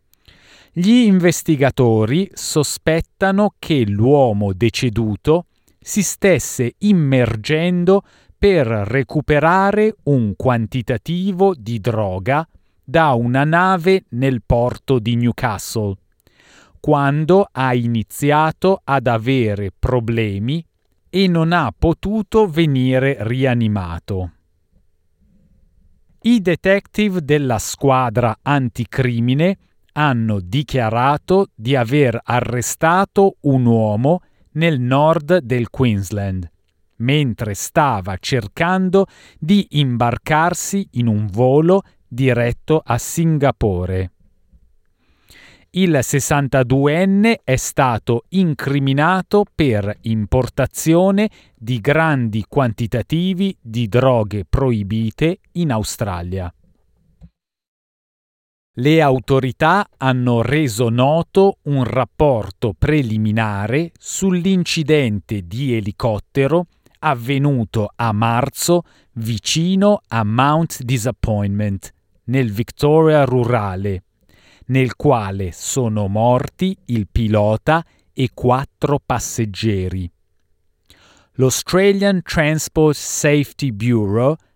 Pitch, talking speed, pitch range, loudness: 130 Hz, 80 wpm, 110-160 Hz, -17 LUFS